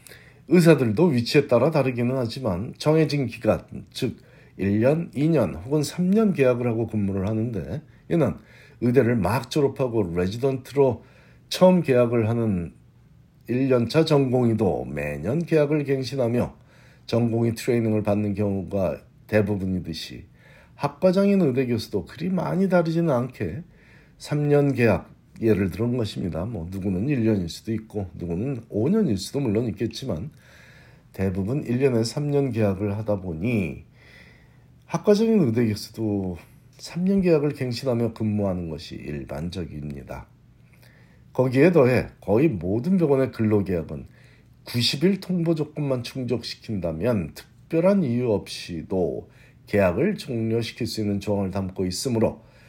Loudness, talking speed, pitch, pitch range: -23 LUFS, 280 characters per minute, 120 Hz, 105-140 Hz